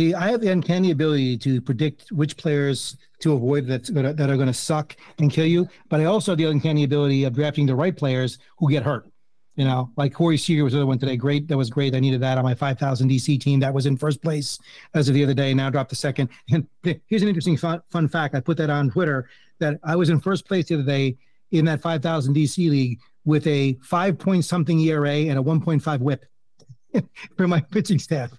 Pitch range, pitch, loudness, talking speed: 135-165 Hz, 145 Hz, -22 LUFS, 240 wpm